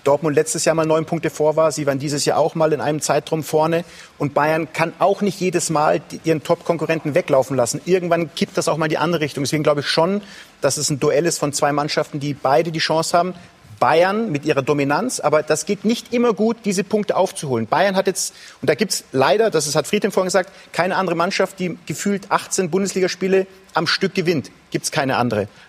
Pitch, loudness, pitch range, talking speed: 165 Hz, -19 LUFS, 150-190 Hz, 220 wpm